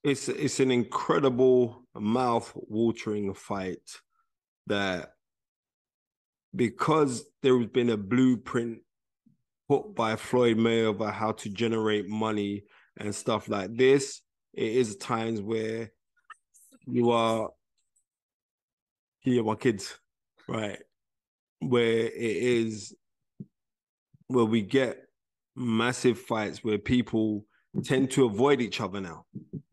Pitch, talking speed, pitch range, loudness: 115 Hz, 105 wpm, 110-130 Hz, -28 LUFS